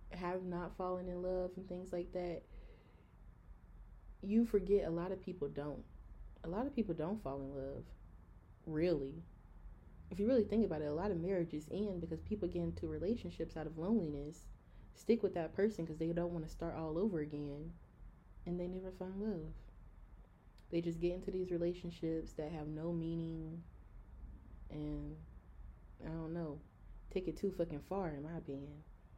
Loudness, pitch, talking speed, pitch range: -41 LUFS, 165 Hz, 175 wpm, 145-185 Hz